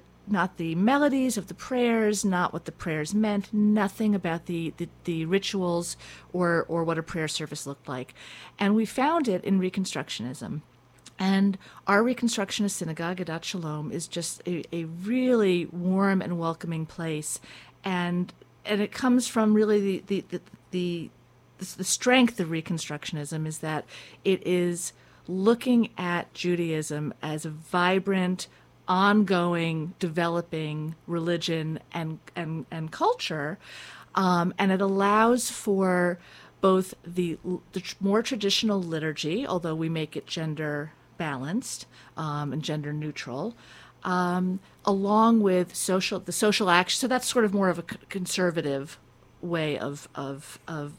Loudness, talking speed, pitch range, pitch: -27 LUFS, 140 wpm, 160-200 Hz, 180 Hz